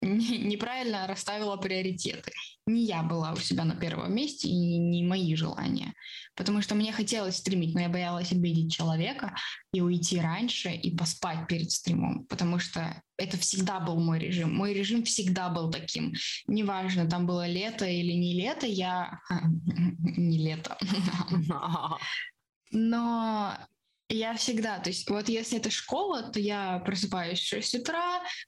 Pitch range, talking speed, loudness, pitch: 175-220 Hz, 145 wpm, -30 LUFS, 185 Hz